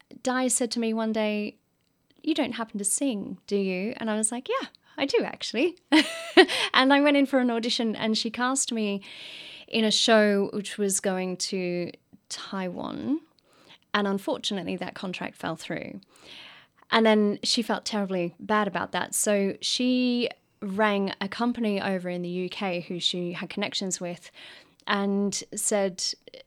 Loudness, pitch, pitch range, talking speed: -26 LUFS, 215 Hz, 195-245 Hz, 160 wpm